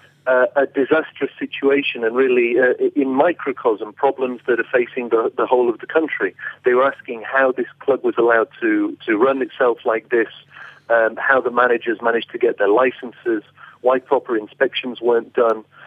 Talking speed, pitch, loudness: 180 wpm, 305 Hz, -18 LUFS